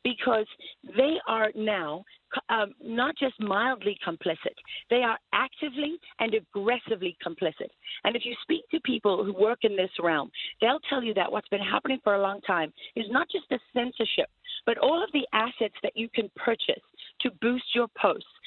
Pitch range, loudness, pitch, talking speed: 205-265 Hz, -28 LUFS, 230 Hz, 180 wpm